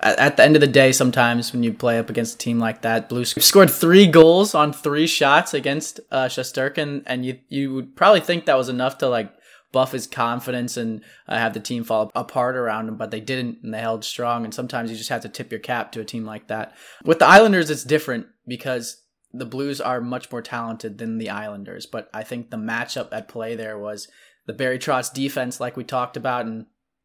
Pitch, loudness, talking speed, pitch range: 125 Hz, -19 LUFS, 225 wpm, 115-140 Hz